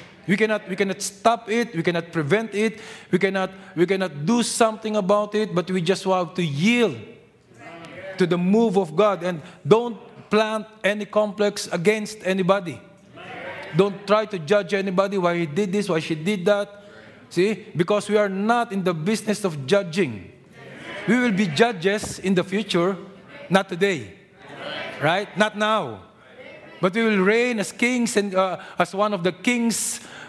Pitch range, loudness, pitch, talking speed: 185-215 Hz, -22 LUFS, 200 Hz, 165 wpm